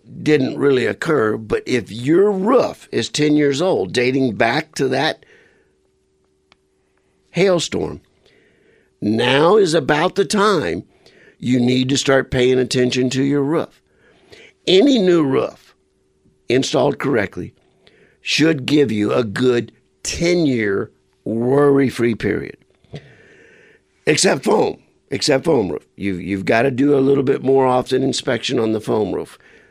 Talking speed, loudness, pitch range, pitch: 125 wpm, -17 LUFS, 110-150 Hz, 130 Hz